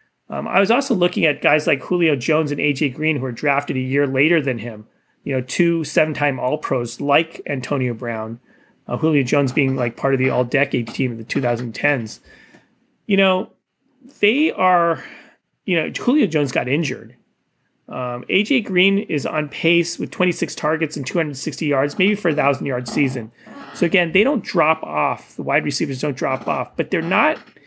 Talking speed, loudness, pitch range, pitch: 190 wpm, -19 LUFS, 130-175 Hz, 150 Hz